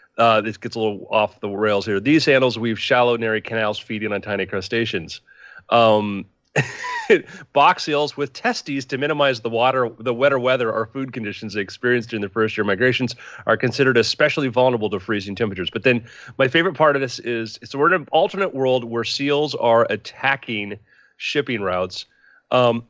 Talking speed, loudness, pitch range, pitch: 180 wpm, -20 LUFS, 110-135 Hz, 120 Hz